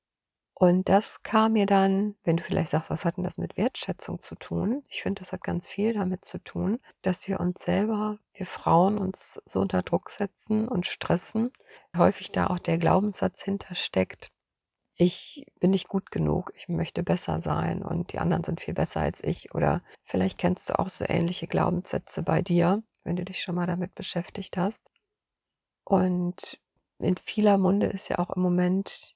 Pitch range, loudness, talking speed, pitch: 175-200 Hz, -27 LUFS, 185 wpm, 185 Hz